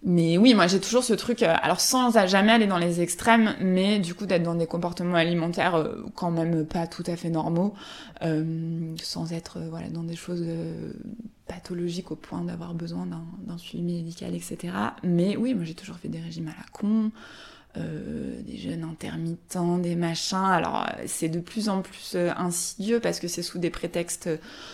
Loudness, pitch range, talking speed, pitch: -26 LUFS, 165-200 Hz, 185 wpm, 175 Hz